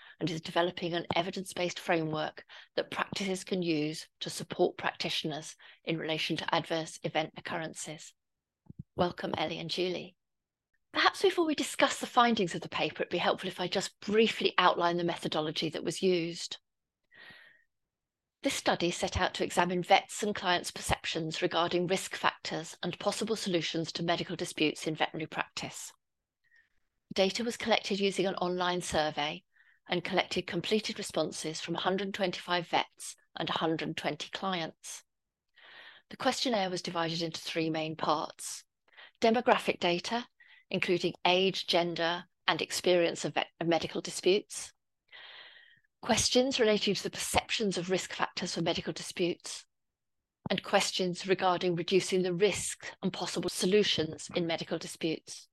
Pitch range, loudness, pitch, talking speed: 165-195 Hz, -31 LUFS, 180 Hz, 140 wpm